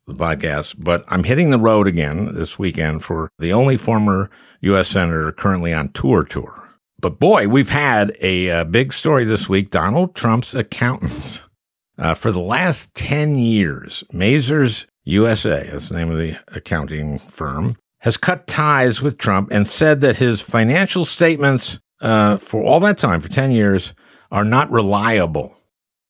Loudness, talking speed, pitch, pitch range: -17 LUFS, 160 wpm, 105 Hz, 90-130 Hz